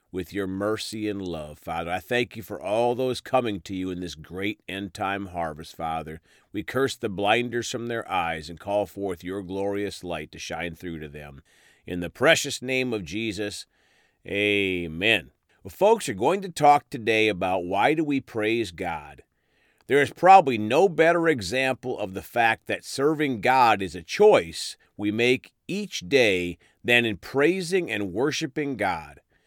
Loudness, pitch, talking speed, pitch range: -24 LUFS, 105 Hz, 175 wpm, 90-130 Hz